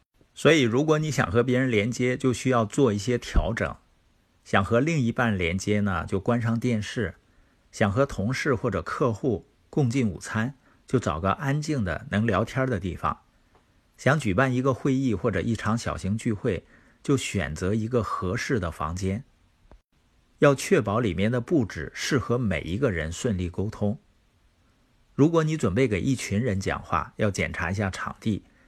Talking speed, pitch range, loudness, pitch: 245 characters per minute, 95-125 Hz, -26 LUFS, 110 Hz